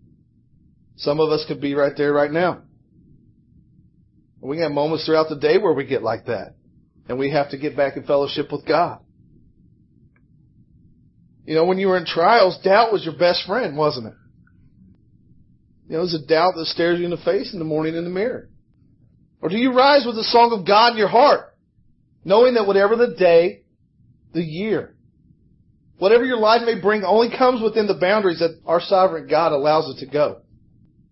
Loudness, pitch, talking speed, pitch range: -19 LUFS, 165 Hz, 190 wpm, 145-200 Hz